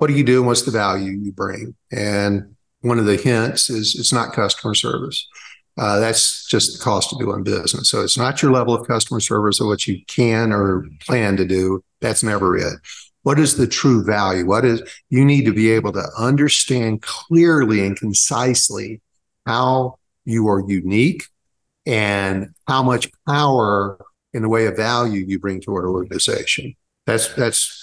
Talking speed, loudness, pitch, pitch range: 180 wpm, -18 LUFS, 110 Hz, 100-125 Hz